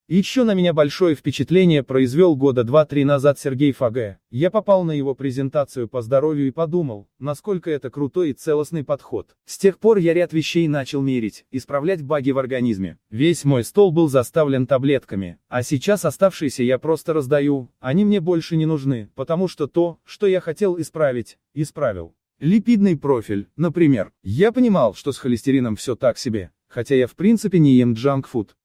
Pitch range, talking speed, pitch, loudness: 130-170 Hz, 170 wpm, 145 Hz, -19 LUFS